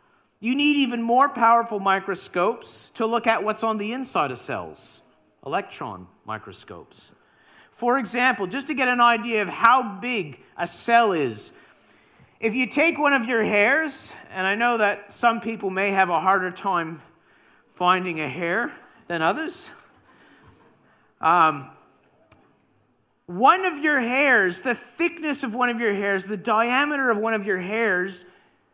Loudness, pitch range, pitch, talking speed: -22 LUFS, 195-260 Hz, 230 Hz, 150 wpm